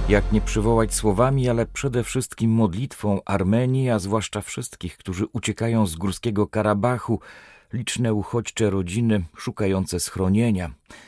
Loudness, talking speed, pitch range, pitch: -23 LUFS, 120 wpm, 100-115 Hz, 110 Hz